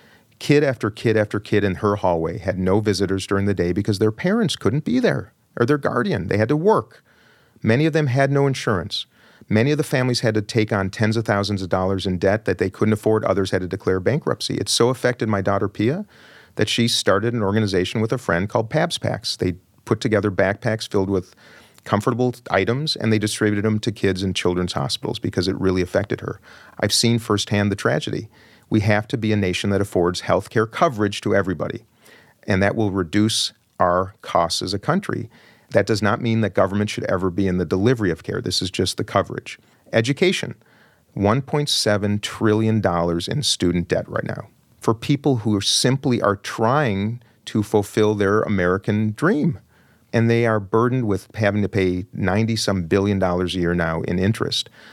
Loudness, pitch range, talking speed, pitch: -21 LUFS, 95-115 Hz, 195 wpm, 105 Hz